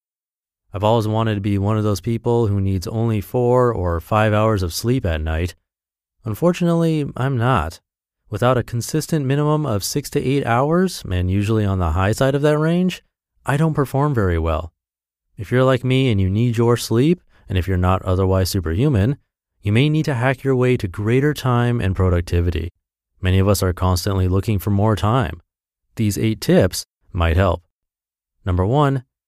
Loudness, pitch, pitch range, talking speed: -19 LUFS, 105 Hz, 95-130 Hz, 180 wpm